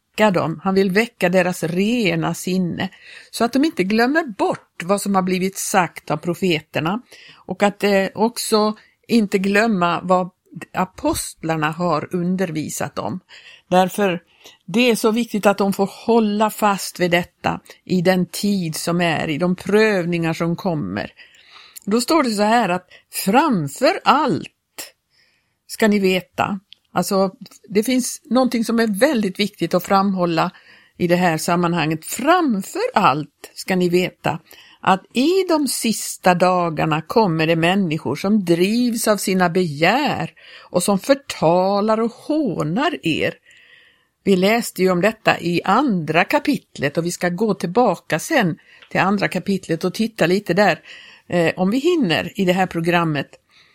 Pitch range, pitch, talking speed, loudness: 175-225 Hz, 195 Hz, 145 wpm, -19 LUFS